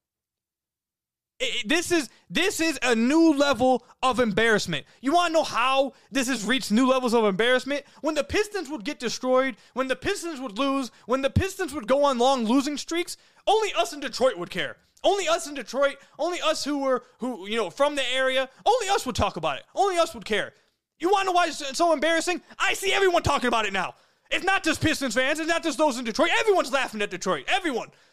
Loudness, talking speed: -24 LUFS, 220 wpm